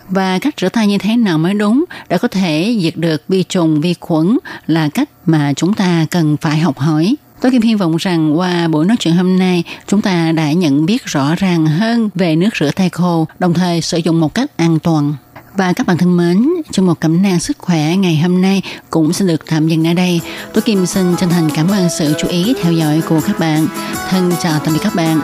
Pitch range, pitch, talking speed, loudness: 160-190 Hz, 175 Hz, 240 wpm, -14 LUFS